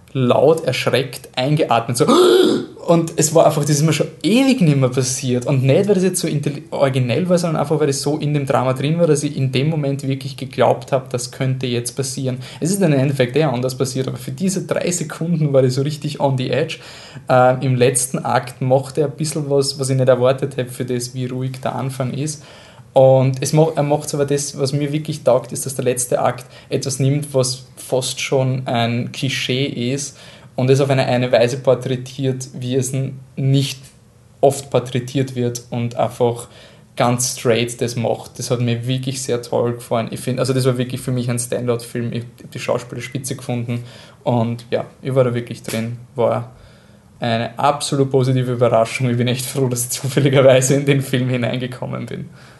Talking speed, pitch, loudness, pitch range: 200 wpm, 130 Hz, -18 LUFS, 125-140 Hz